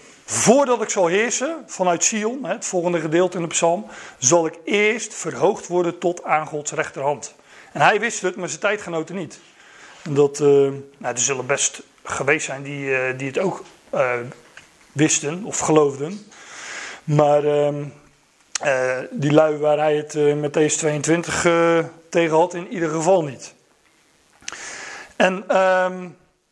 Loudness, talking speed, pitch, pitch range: -20 LUFS, 155 wpm, 160 Hz, 145-180 Hz